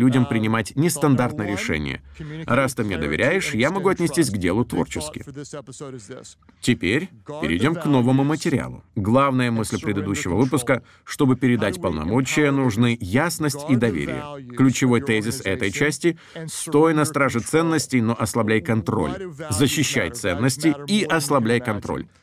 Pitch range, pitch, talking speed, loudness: 110-145 Hz, 130 Hz, 125 wpm, -21 LUFS